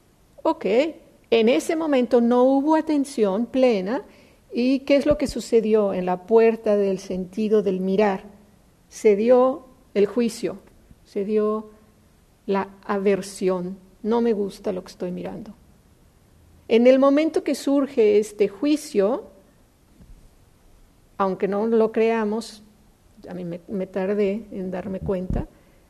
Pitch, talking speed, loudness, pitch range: 215 Hz, 125 wpm, -22 LUFS, 195-255 Hz